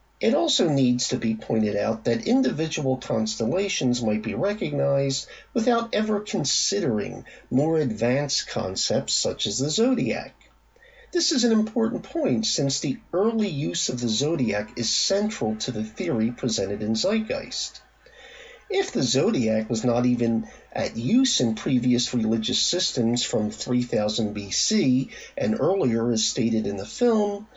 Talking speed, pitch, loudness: 140 wpm, 130 Hz, -24 LUFS